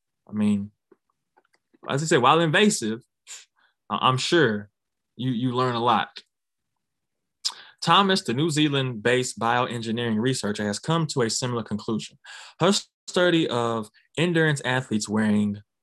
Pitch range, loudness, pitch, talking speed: 110-155 Hz, -23 LUFS, 120 Hz, 120 wpm